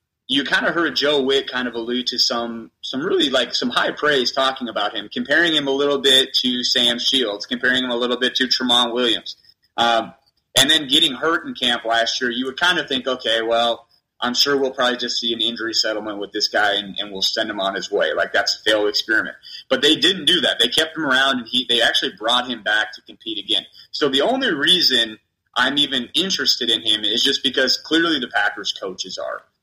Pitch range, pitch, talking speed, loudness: 115-135 Hz, 125 Hz, 230 wpm, -18 LUFS